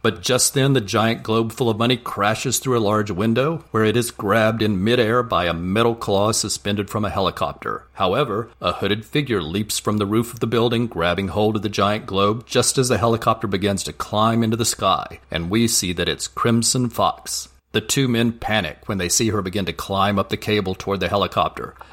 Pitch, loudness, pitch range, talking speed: 110 Hz, -20 LUFS, 100-115 Hz, 215 wpm